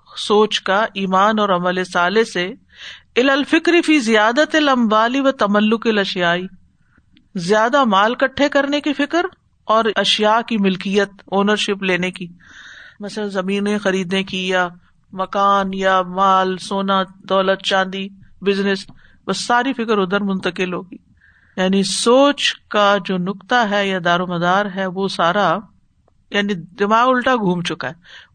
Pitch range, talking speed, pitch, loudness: 190-225 Hz, 125 wpm, 200 Hz, -17 LUFS